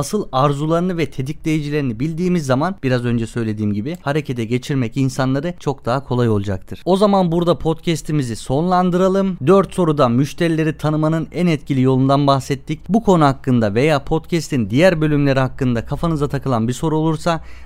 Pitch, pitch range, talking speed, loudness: 145 Hz, 130-165 Hz, 145 wpm, -18 LUFS